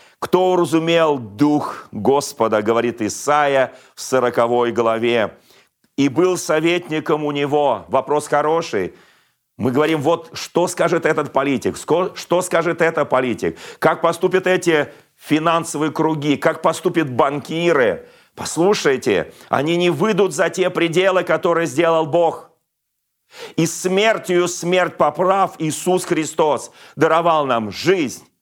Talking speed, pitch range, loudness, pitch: 115 wpm, 145-175 Hz, -18 LUFS, 165 Hz